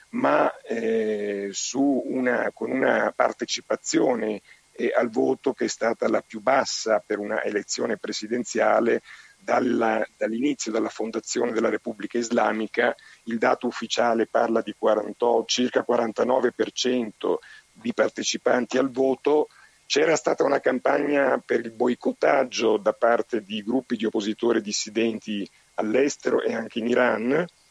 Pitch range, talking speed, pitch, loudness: 110-125 Hz, 125 wpm, 115 Hz, -24 LUFS